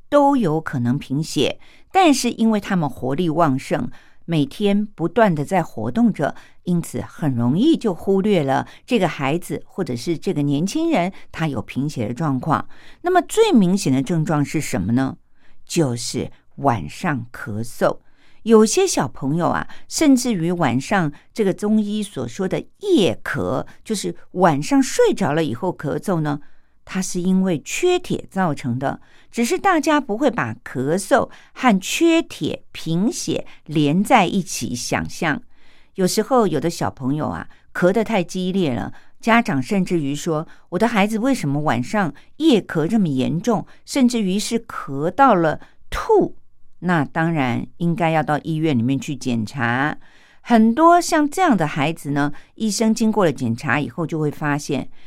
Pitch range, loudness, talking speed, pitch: 145-225 Hz, -20 LUFS, 230 characters per minute, 175 Hz